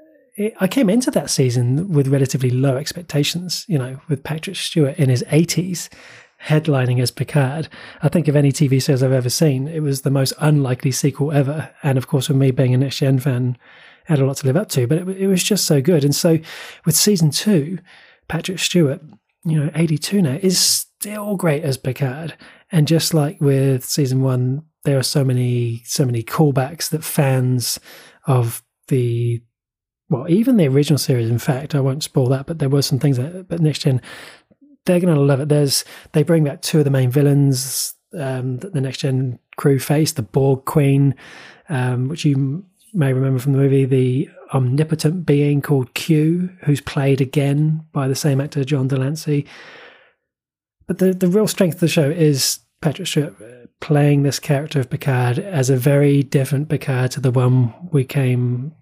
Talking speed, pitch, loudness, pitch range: 190 wpm, 145 Hz, -18 LUFS, 135-160 Hz